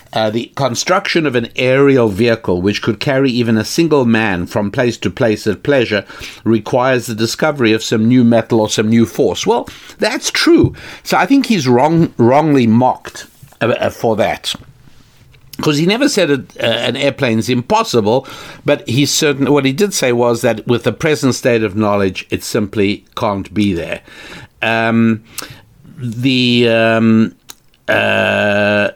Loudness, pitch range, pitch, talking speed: -14 LUFS, 110-140 Hz, 120 Hz, 160 wpm